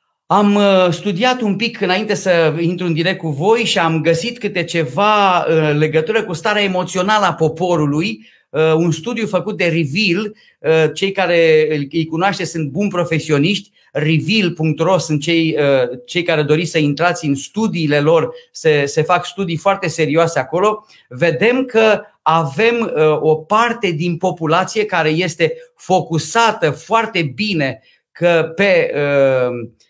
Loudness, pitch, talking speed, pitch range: -15 LUFS, 175 Hz, 135 wpm, 160-205 Hz